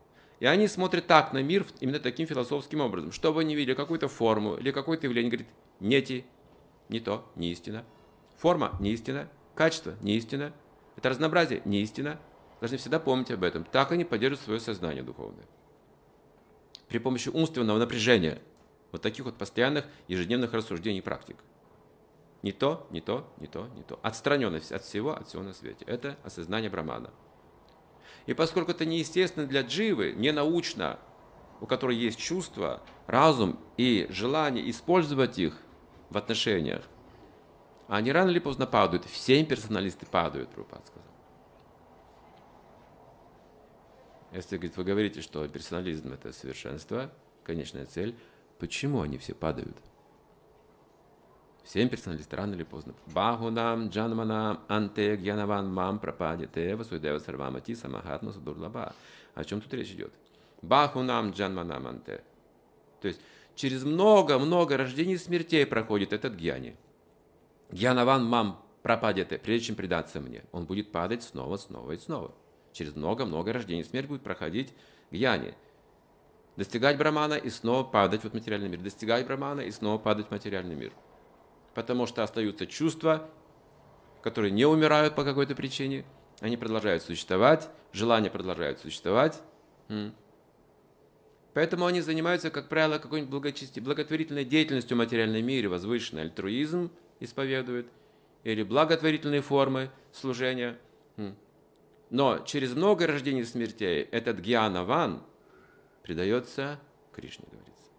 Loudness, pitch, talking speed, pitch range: -29 LUFS, 120 Hz, 130 wpm, 100-140 Hz